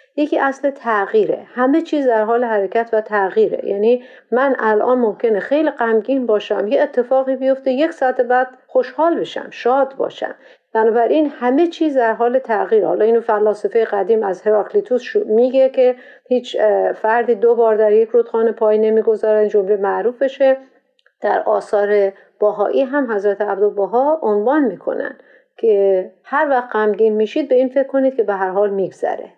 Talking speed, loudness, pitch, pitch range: 155 wpm, -16 LUFS, 240 Hz, 215-270 Hz